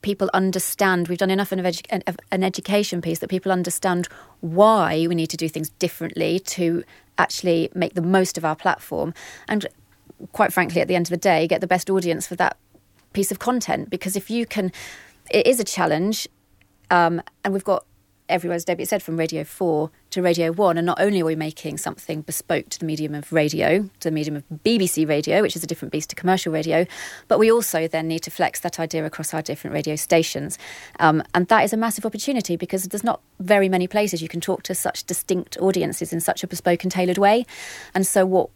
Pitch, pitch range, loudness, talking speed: 180 Hz, 165-190 Hz, -22 LUFS, 215 wpm